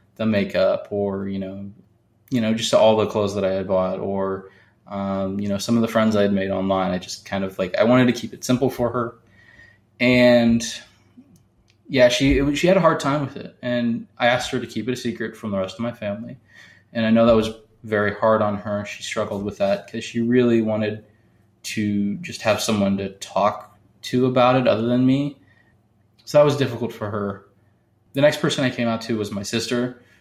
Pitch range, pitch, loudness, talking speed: 100-120 Hz, 110 Hz, -21 LUFS, 225 wpm